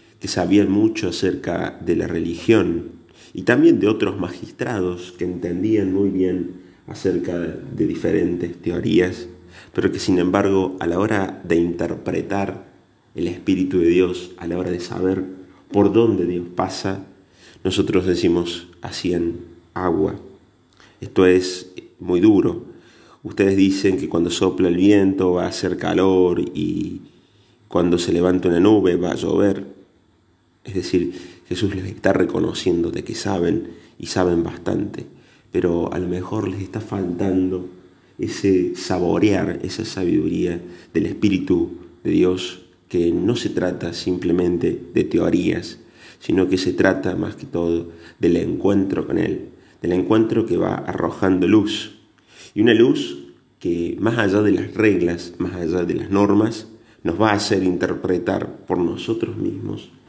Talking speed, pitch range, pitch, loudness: 145 wpm, 90-95 Hz, 90 Hz, -20 LUFS